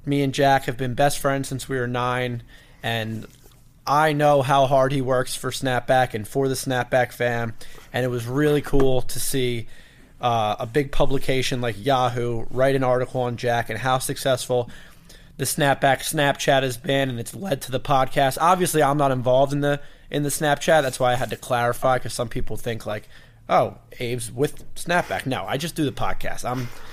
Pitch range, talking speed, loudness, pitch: 125-140 Hz, 195 wpm, -22 LUFS, 130 Hz